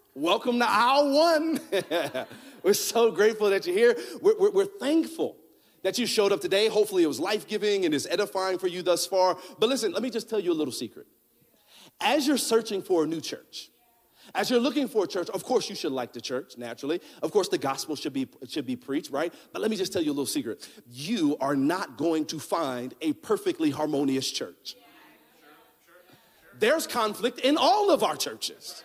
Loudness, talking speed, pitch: -26 LUFS, 205 wpm, 210 Hz